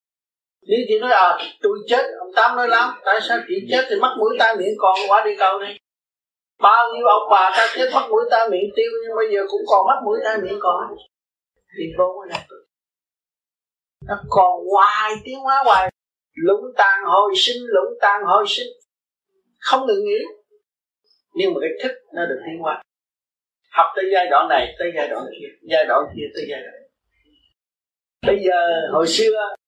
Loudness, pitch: -18 LUFS, 225 Hz